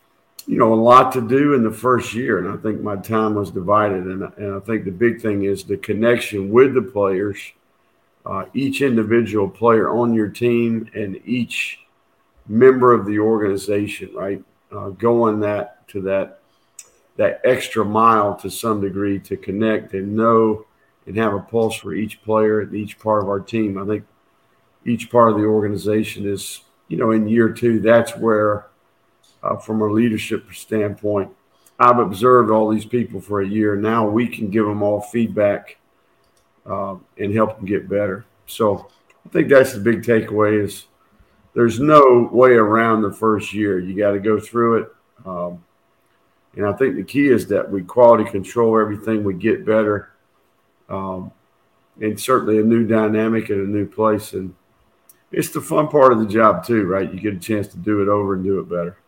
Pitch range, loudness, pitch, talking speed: 100-115 Hz, -18 LUFS, 105 Hz, 185 wpm